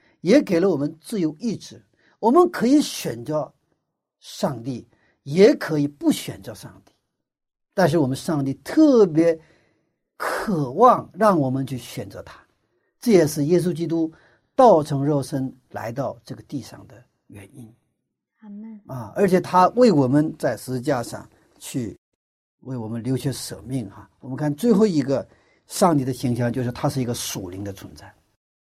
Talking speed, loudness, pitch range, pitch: 225 characters per minute, -21 LUFS, 125-180 Hz, 145 Hz